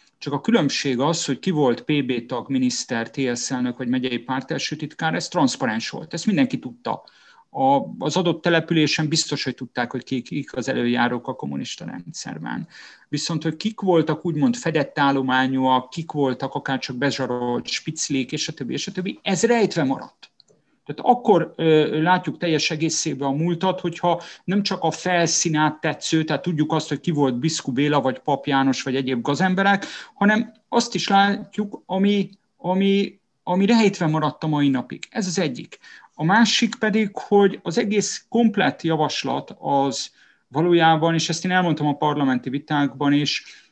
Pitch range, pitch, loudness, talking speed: 140-195 Hz, 160 Hz, -22 LUFS, 165 wpm